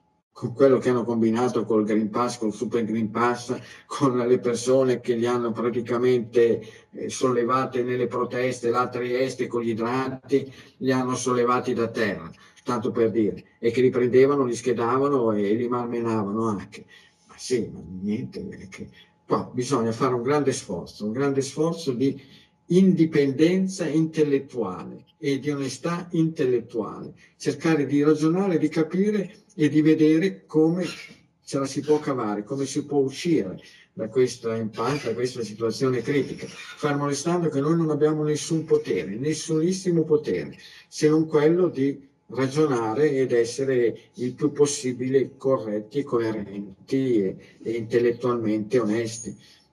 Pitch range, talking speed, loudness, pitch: 120-150 Hz, 145 wpm, -24 LUFS, 130 Hz